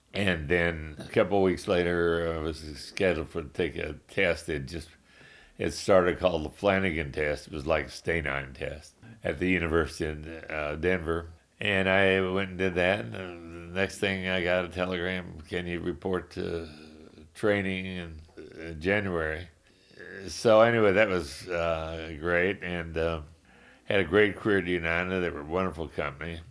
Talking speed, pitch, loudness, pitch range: 165 wpm, 85 Hz, -28 LUFS, 80-95 Hz